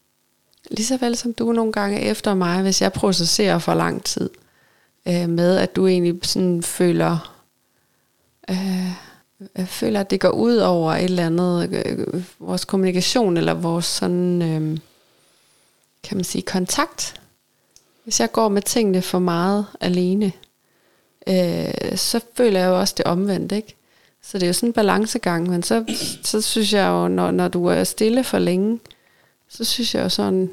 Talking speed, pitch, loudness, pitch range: 165 wpm, 185 Hz, -20 LUFS, 175-215 Hz